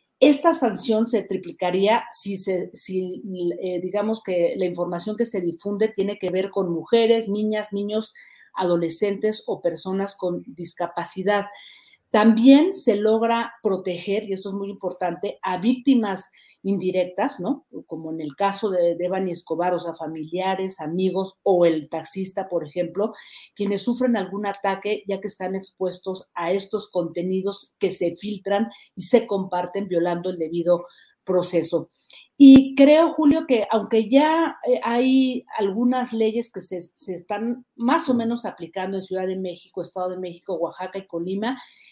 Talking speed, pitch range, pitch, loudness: 150 wpm, 180-225 Hz, 195 Hz, -22 LUFS